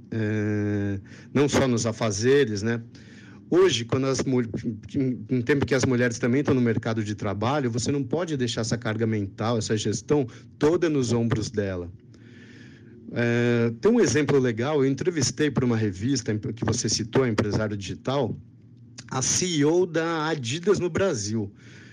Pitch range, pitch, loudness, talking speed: 110-135 Hz, 120 Hz, -25 LUFS, 150 wpm